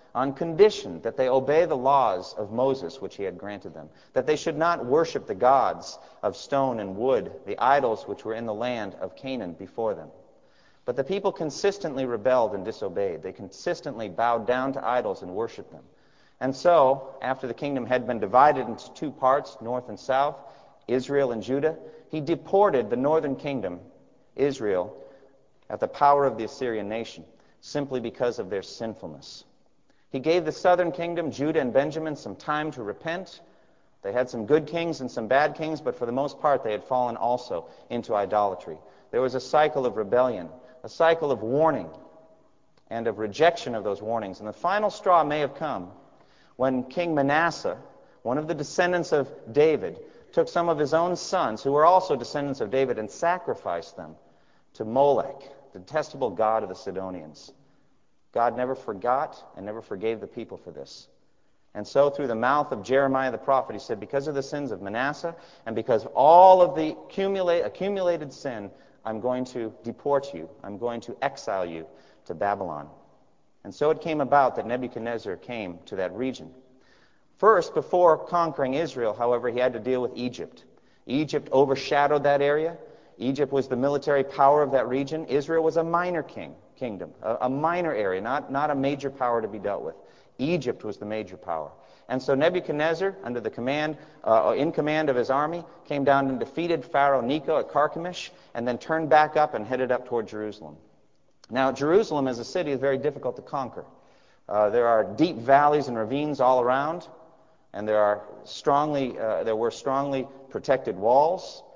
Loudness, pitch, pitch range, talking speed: -25 LUFS, 140 Hz, 125-160 Hz, 180 wpm